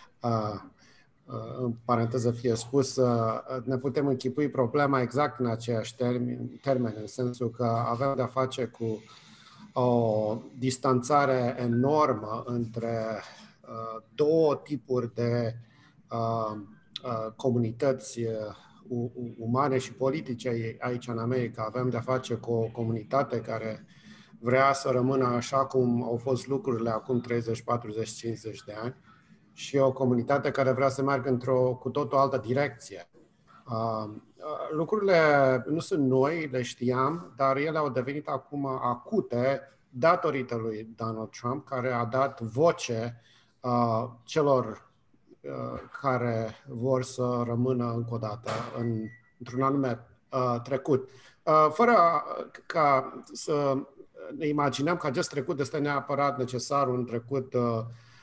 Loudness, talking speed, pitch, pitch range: -28 LUFS, 125 wpm, 125 Hz, 115-135 Hz